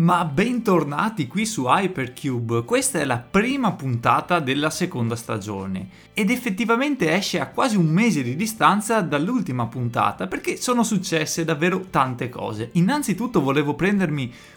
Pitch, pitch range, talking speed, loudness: 170 Hz, 130-215 Hz, 135 wpm, -22 LUFS